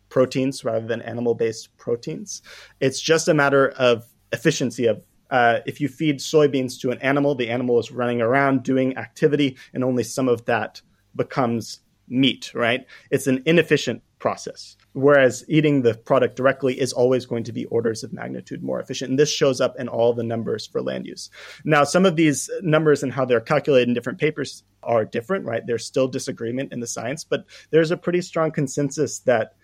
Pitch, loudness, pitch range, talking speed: 130 Hz, -21 LUFS, 120-145 Hz, 190 wpm